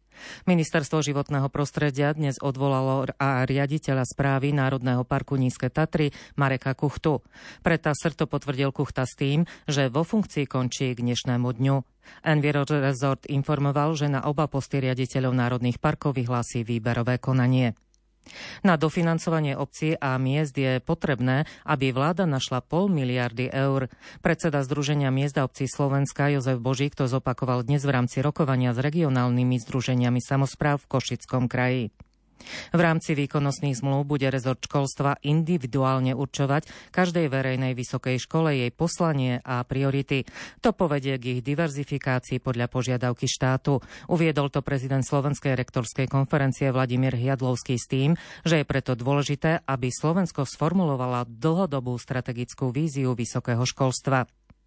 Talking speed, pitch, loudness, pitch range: 135 wpm, 135 Hz, -25 LUFS, 130-150 Hz